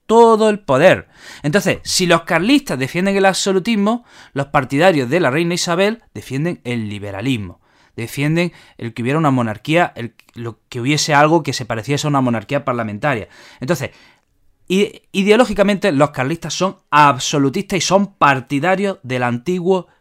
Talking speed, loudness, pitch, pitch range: 140 wpm, -16 LUFS, 150 Hz, 130-190 Hz